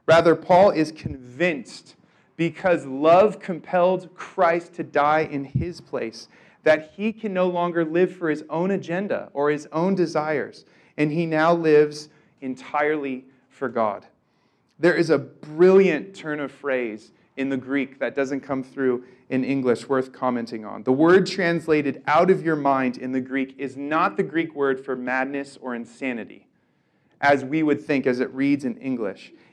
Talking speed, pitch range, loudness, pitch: 165 wpm, 130-170 Hz, -22 LUFS, 150 Hz